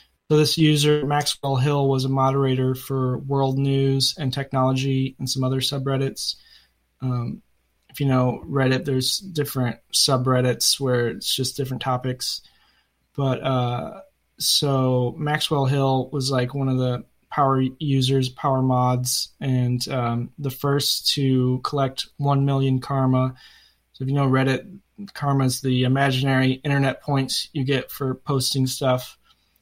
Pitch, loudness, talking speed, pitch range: 130 Hz, -22 LUFS, 140 wpm, 130-140 Hz